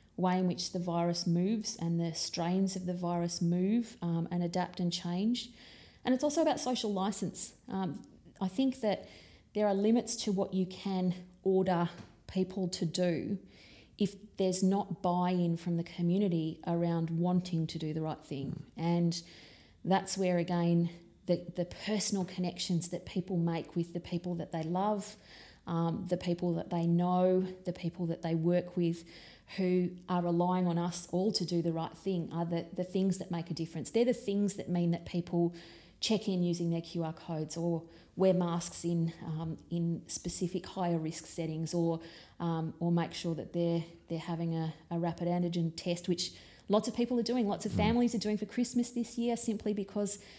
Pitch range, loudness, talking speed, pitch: 170-190 Hz, -33 LUFS, 185 wpm, 175 Hz